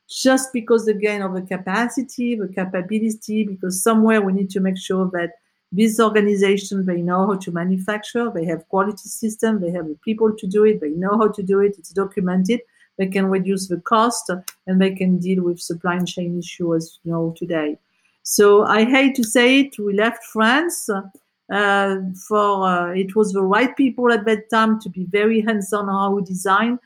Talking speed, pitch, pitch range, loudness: 190 wpm, 200 Hz, 185-220 Hz, -19 LUFS